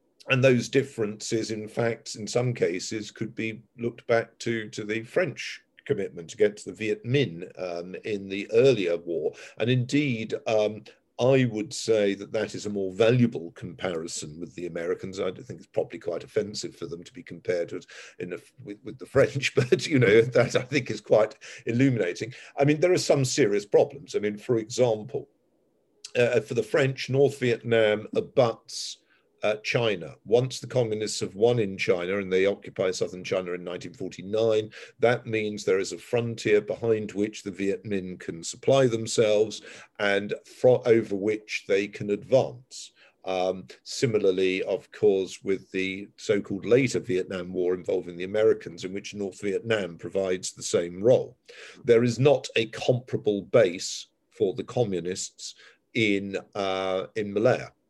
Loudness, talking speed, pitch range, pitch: -26 LUFS, 170 wpm, 100-125 Hz, 110 Hz